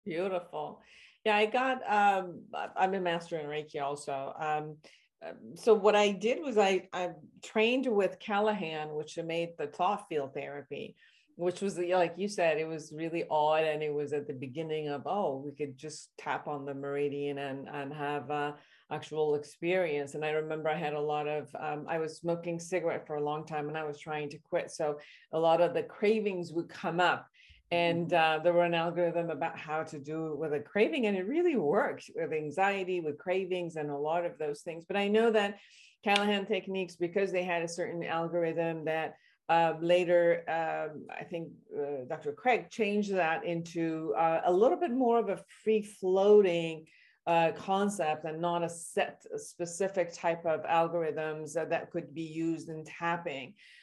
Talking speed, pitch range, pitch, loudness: 190 wpm, 155-185 Hz, 165 Hz, -32 LUFS